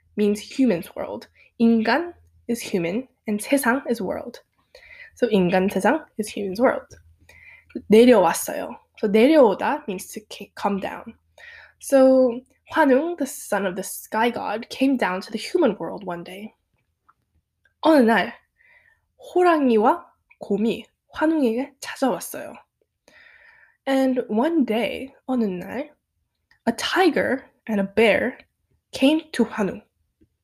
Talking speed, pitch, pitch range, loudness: 115 wpm, 235 Hz, 205-275 Hz, -21 LUFS